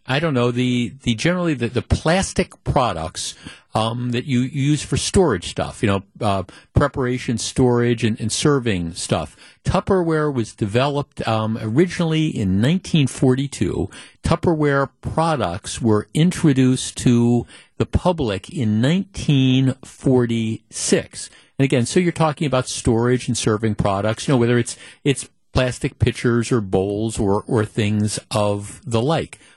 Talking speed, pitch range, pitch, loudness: 135 wpm, 110-140 Hz, 120 Hz, -20 LUFS